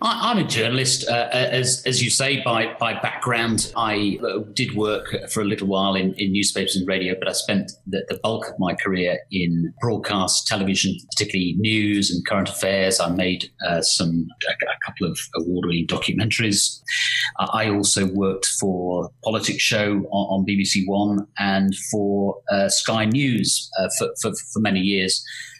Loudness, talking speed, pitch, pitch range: -21 LUFS, 165 wpm, 100 Hz, 95-110 Hz